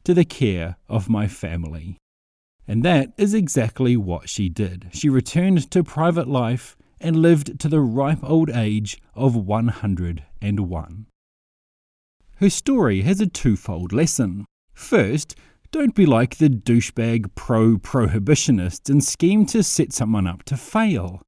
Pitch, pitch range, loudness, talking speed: 120 Hz, 100-160 Hz, -20 LUFS, 135 wpm